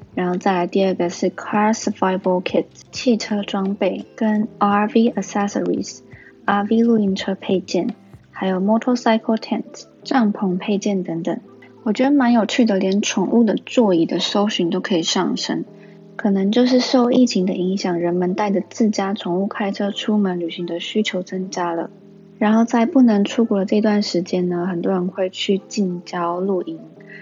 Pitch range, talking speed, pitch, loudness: 185-220 Hz, 315 characters per minute, 200 Hz, -19 LUFS